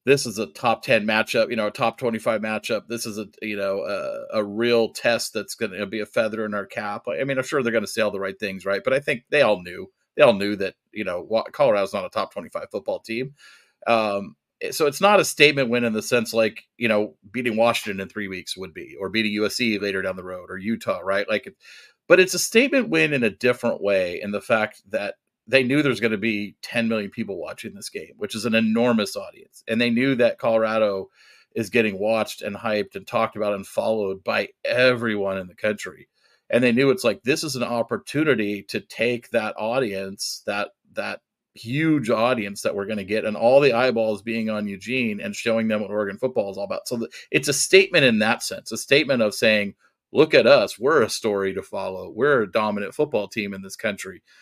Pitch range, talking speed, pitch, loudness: 105-125 Hz, 230 wpm, 110 Hz, -22 LUFS